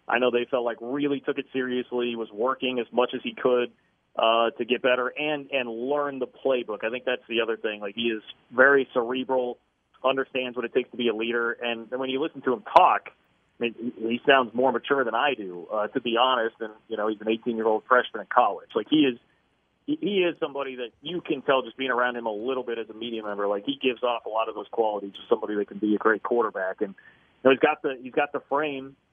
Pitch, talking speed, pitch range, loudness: 125 Hz, 260 wpm, 115-135 Hz, -26 LUFS